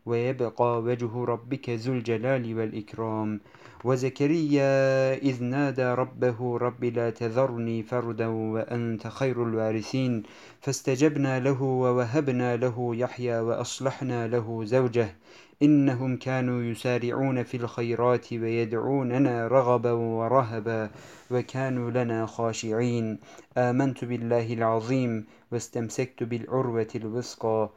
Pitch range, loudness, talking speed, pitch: 115-130 Hz, -27 LUFS, 90 wpm, 120 Hz